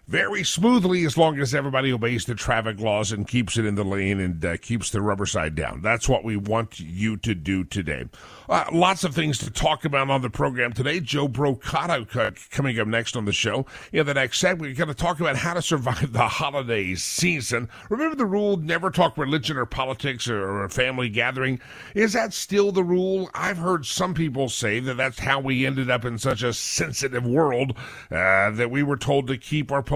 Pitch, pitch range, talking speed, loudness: 130 Hz, 115-160 Hz, 210 wpm, -23 LUFS